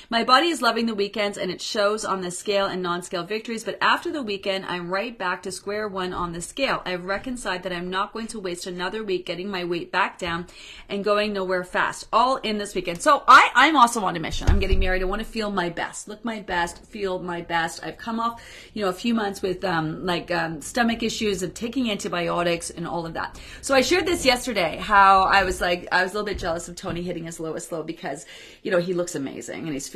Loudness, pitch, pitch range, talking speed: -23 LUFS, 190 Hz, 175-215 Hz, 250 wpm